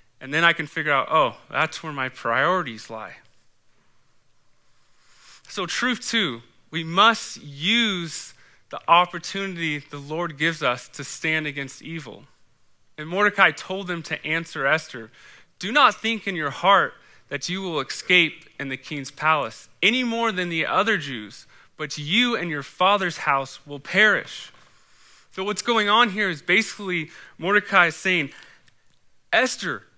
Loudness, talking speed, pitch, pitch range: -22 LUFS, 150 wpm, 160 Hz, 140-190 Hz